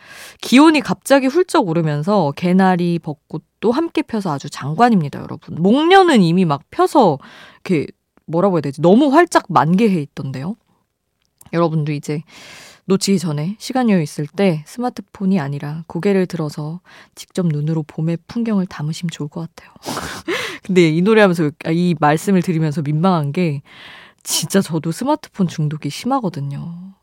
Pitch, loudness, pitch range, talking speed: 175 Hz, -17 LUFS, 155-210 Hz, 330 characters per minute